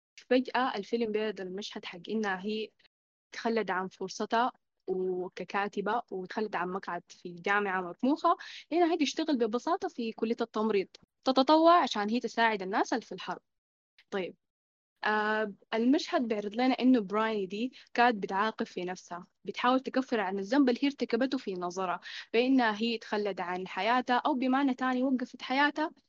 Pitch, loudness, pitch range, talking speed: 225 Hz, -30 LUFS, 195-255 Hz, 145 wpm